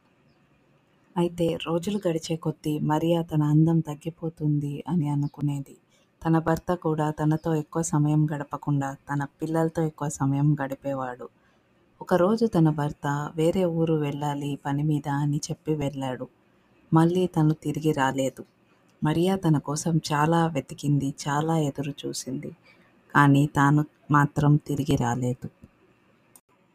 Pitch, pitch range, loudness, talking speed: 150 Hz, 145-165 Hz, -25 LUFS, 110 wpm